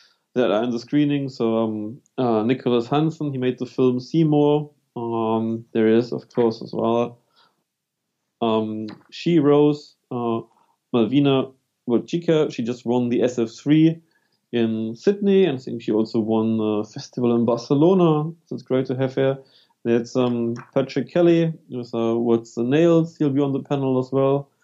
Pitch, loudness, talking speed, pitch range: 125 Hz, -21 LUFS, 160 wpm, 115-145 Hz